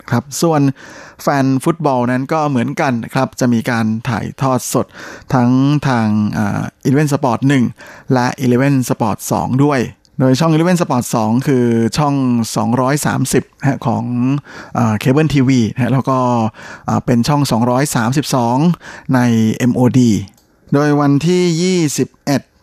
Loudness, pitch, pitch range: -15 LUFS, 130 Hz, 120-140 Hz